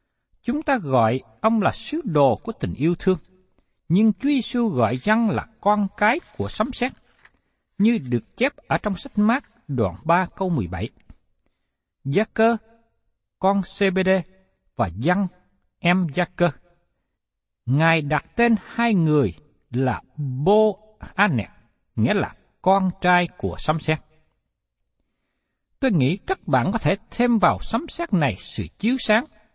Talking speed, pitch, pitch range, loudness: 145 wpm, 190 Hz, 155-225 Hz, -22 LUFS